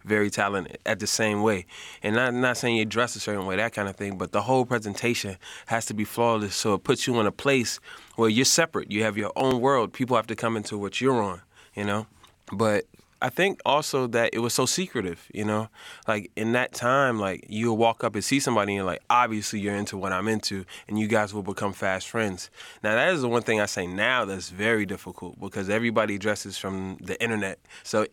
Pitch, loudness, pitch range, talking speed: 105 Hz, -26 LUFS, 100-115 Hz, 235 wpm